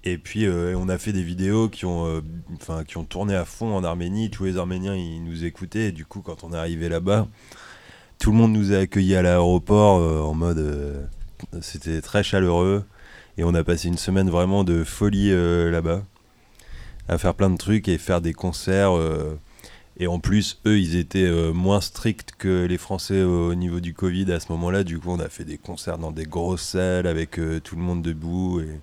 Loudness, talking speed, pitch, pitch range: -23 LUFS, 225 wpm, 90 Hz, 85-100 Hz